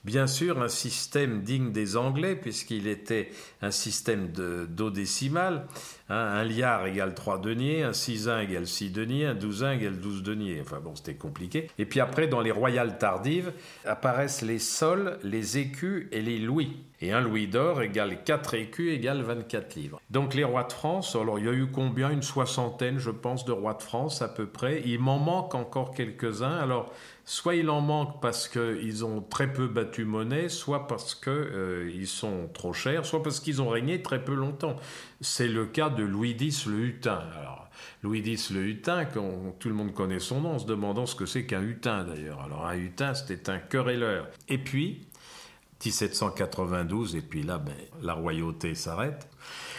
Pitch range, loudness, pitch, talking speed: 105-140 Hz, -30 LUFS, 120 Hz, 190 wpm